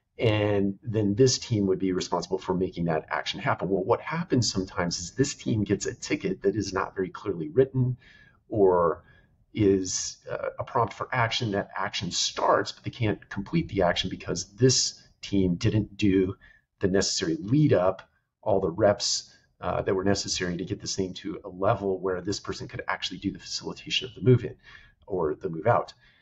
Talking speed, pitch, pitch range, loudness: 190 wpm, 100 Hz, 95-115 Hz, -27 LUFS